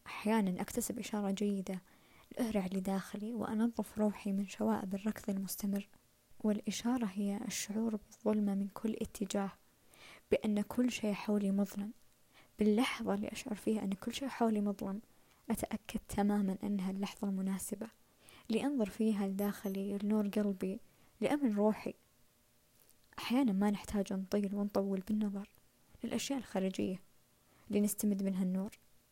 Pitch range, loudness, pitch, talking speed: 195-220 Hz, -37 LUFS, 205 Hz, 115 wpm